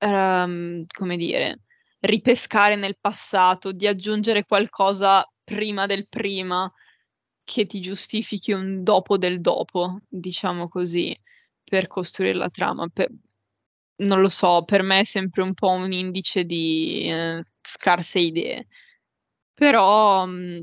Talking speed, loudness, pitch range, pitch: 125 wpm, -22 LUFS, 180-205 Hz, 190 Hz